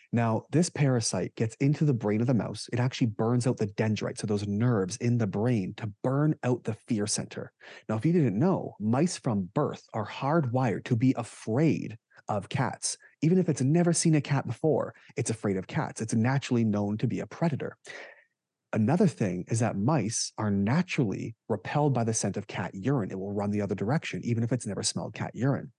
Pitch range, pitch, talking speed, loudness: 110-140 Hz, 120 Hz, 205 wpm, -28 LUFS